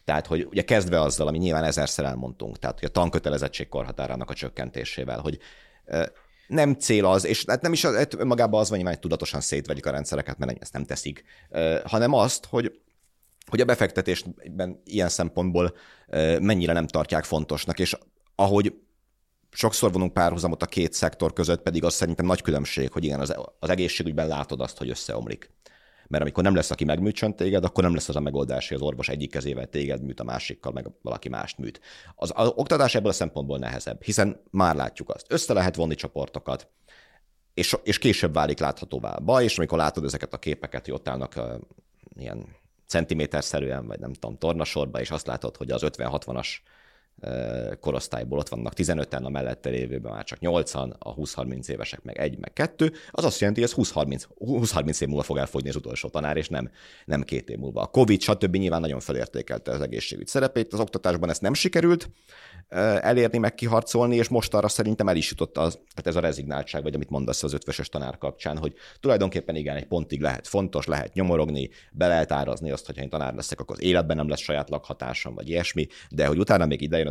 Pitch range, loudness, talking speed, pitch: 70-90 Hz, -26 LUFS, 190 wpm, 80 Hz